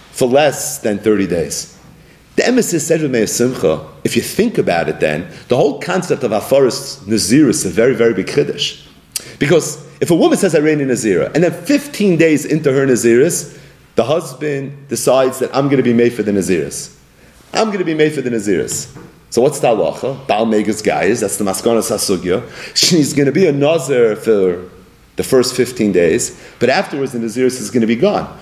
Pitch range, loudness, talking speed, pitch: 115-155 Hz, -15 LUFS, 205 wpm, 130 Hz